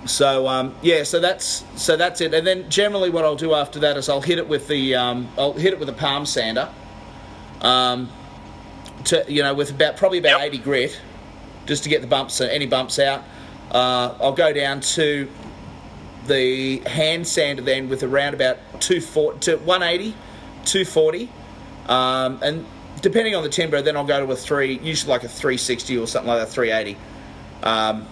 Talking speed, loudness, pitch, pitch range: 195 wpm, -20 LUFS, 140 Hz, 125-160 Hz